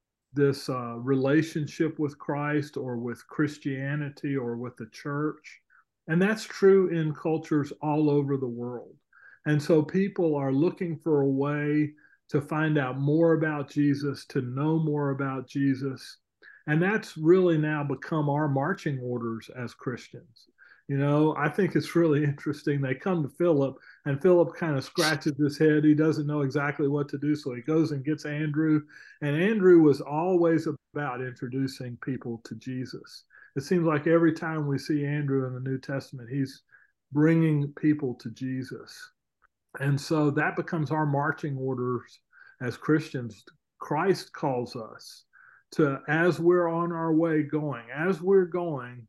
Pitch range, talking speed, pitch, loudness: 135-160 Hz, 160 wpm, 150 Hz, -27 LUFS